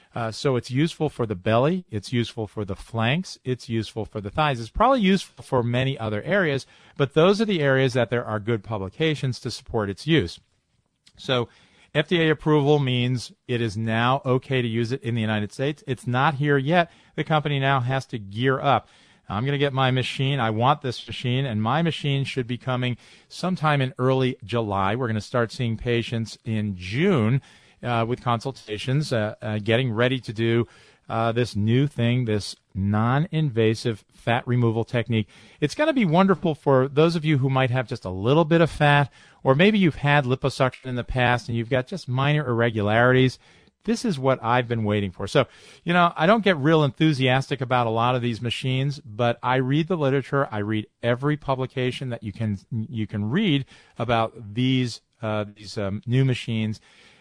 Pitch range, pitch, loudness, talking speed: 115-140 Hz, 125 Hz, -23 LUFS, 195 wpm